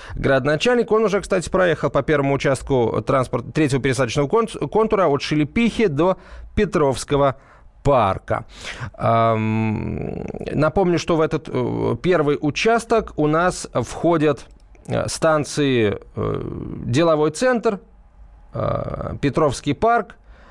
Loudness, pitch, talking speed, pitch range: -20 LUFS, 150 Hz, 90 wpm, 135-190 Hz